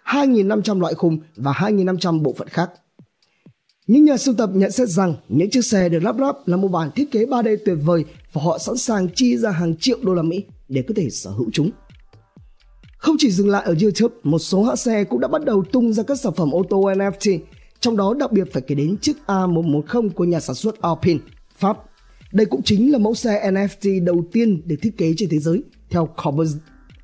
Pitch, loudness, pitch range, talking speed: 195 Hz, -19 LUFS, 165-220 Hz, 220 wpm